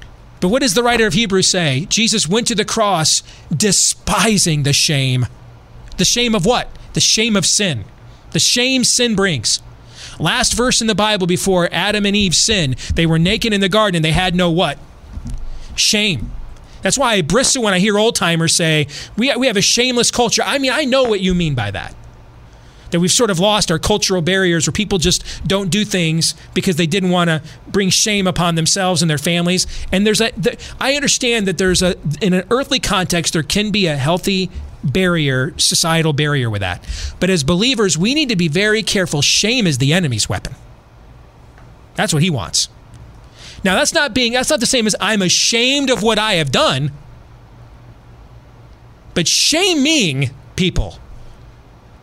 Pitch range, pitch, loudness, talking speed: 160-215 Hz, 185 Hz, -15 LUFS, 185 wpm